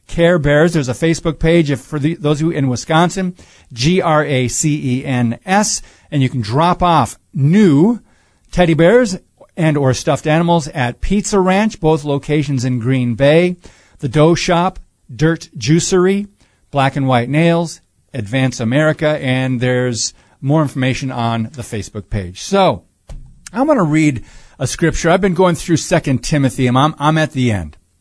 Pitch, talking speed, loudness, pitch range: 150 Hz, 165 wpm, -15 LUFS, 130-170 Hz